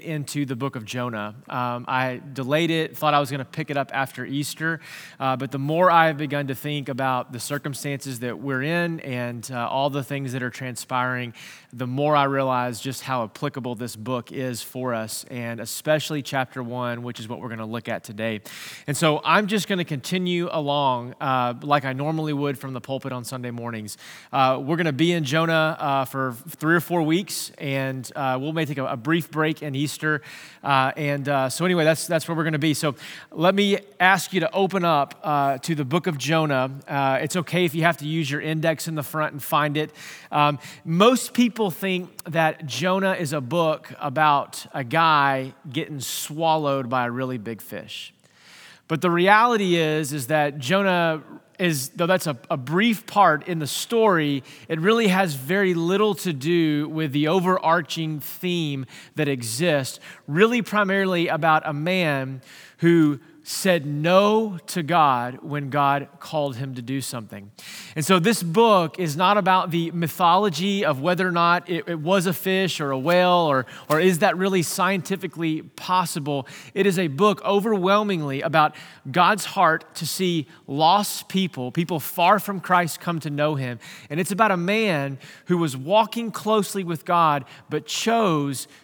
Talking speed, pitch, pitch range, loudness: 185 wpm, 155 Hz, 135-175 Hz, -23 LUFS